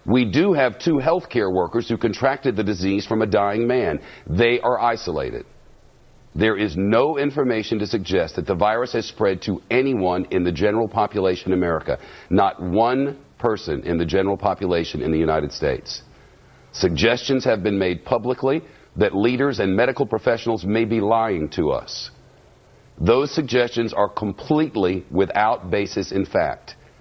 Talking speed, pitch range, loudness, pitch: 160 wpm, 95-125 Hz, -21 LUFS, 110 Hz